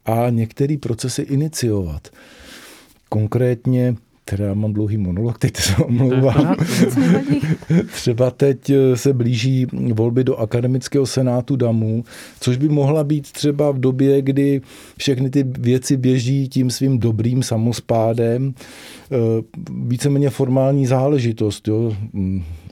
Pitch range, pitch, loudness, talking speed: 115-140 Hz, 130 Hz, -18 LUFS, 110 wpm